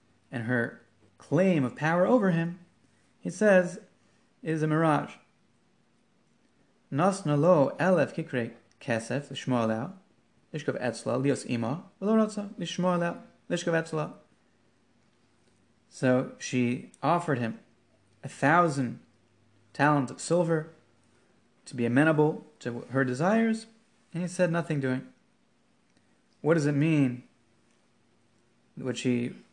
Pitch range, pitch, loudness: 120-175 Hz, 150 Hz, -28 LUFS